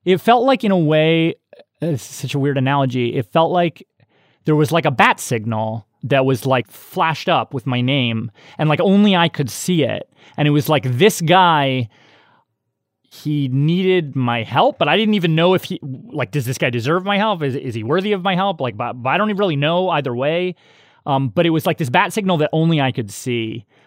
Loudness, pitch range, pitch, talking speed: -17 LUFS, 130-180 Hz, 150 Hz, 225 wpm